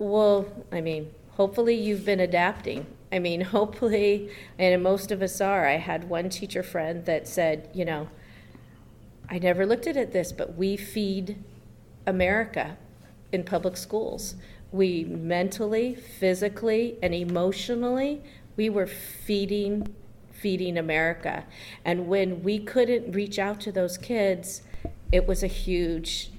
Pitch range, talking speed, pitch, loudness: 170-205 Hz, 135 wpm, 190 Hz, -27 LUFS